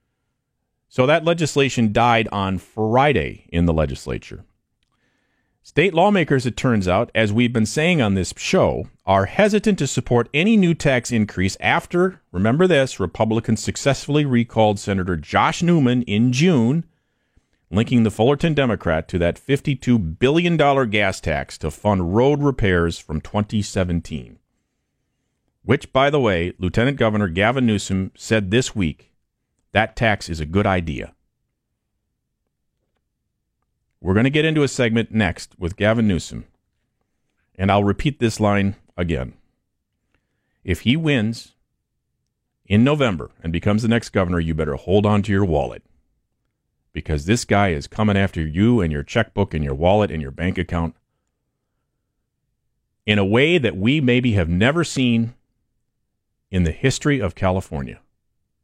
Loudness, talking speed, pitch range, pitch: -19 LUFS, 140 wpm, 90-125 Hz, 110 Hz